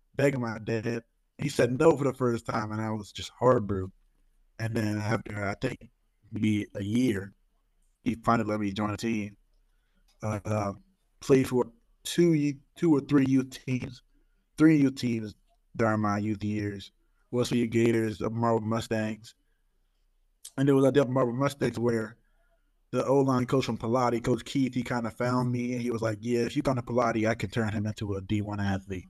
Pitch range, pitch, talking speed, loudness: 105-125 Hz, 115 Hz, 185 wpm, -28 LUFS